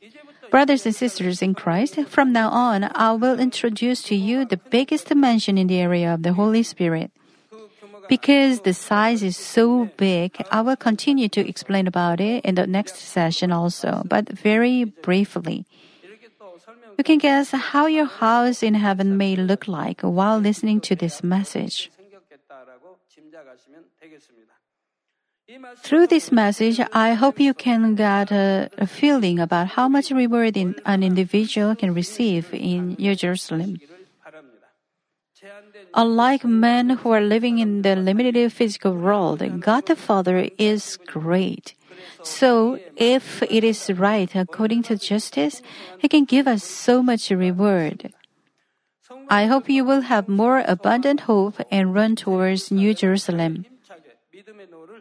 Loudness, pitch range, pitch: -20 LUFS, 185-240 Hz, 210 Hz